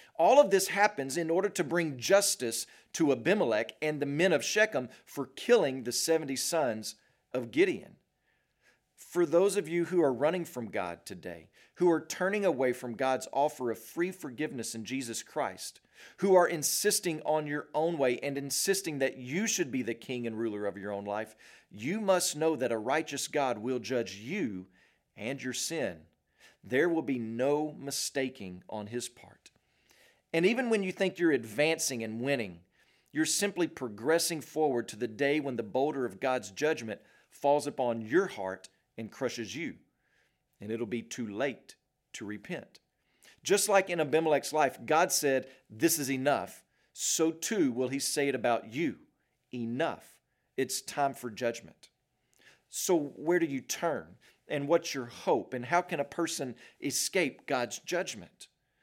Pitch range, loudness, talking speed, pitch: 120-165 Hz, -31 LUFS, 165 wpm, 140 Hz